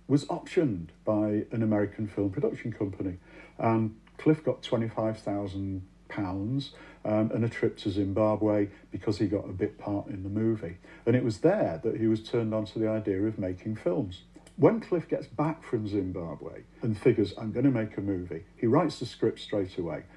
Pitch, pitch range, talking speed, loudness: 110 Hz, 100-115 Hz, 190 wpm, -30 LUFS